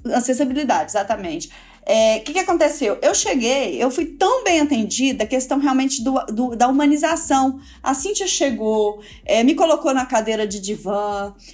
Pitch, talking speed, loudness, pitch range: 265 Hz, 160 wpm, -18 LUFS, 225-305 Hz